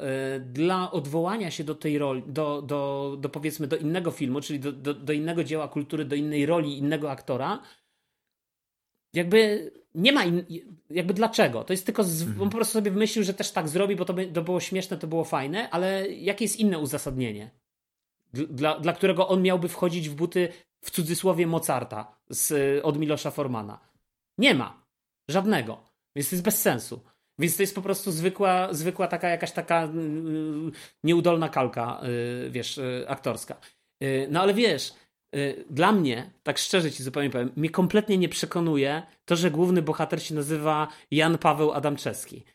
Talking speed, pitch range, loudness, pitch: 165 wpm, 145-185 Hz, -26 LUFS, 160 Hz